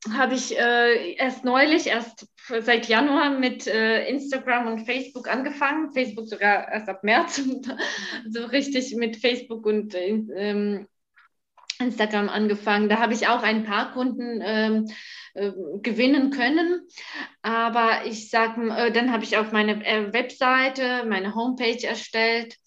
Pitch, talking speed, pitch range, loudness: 230 Hz, 135 wpm, 215-255 Hz, -23 LUFS